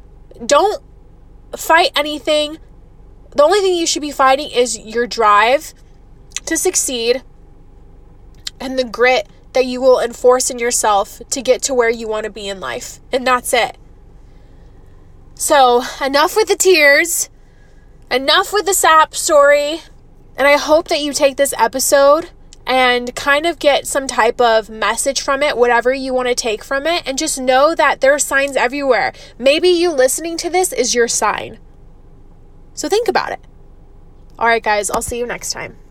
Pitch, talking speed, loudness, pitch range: 275 Hz, 165 wpm, -14 LUFS, 245-305 Hz